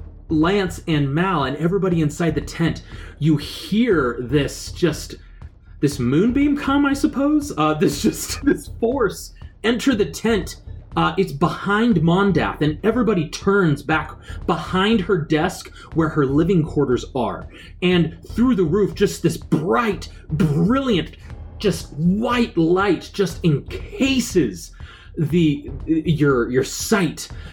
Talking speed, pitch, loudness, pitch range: 125 wpm, 170 Hz, -20 LUFS, 155-200 Hz